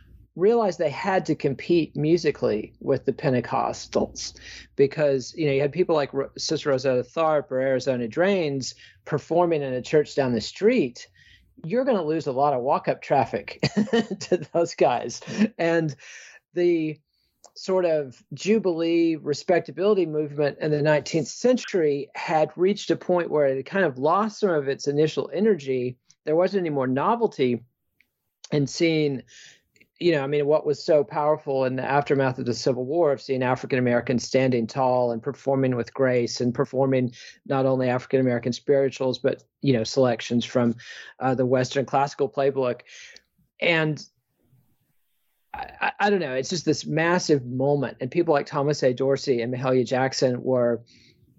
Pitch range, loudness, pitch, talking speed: 130-165 Hz, -24 LUFS, 140 Hz, 160 wpm